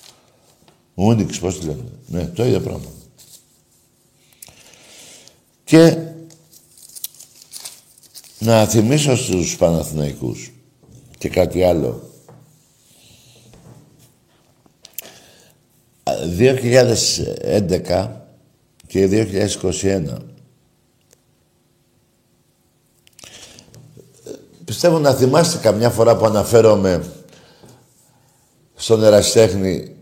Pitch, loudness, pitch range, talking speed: 110 Hz, -16 LUFS, 95-130 Hz, 55 wpm